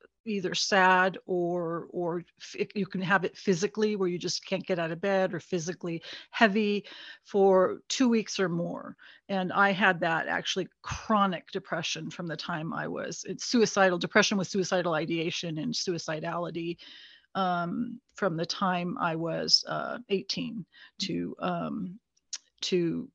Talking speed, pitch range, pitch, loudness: 145 wpm, 170-205 Hz, 185 Hz, -29 LUFS